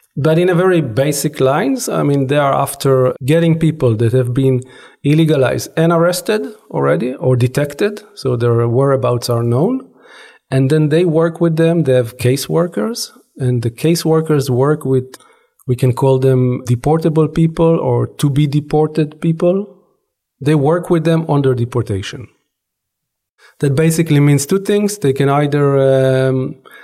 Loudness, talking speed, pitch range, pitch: -14 LUFS, 150 wpm, 130-165 Hz, 145 Hz